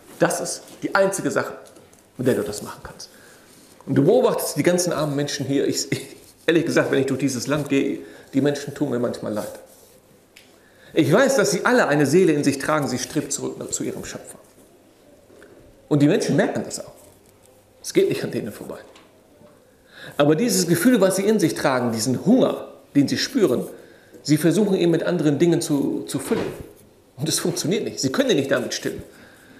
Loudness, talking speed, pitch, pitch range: -21 LUFS, 190 wpm, 150 Hz, 140-190 Hz